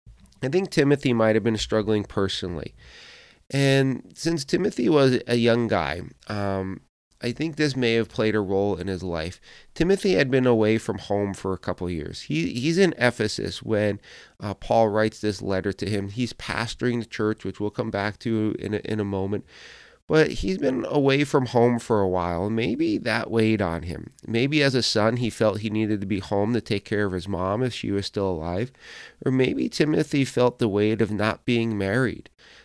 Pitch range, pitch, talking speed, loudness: 100-125 Hz, 110 Hz, 200 wpm, -24 LUFS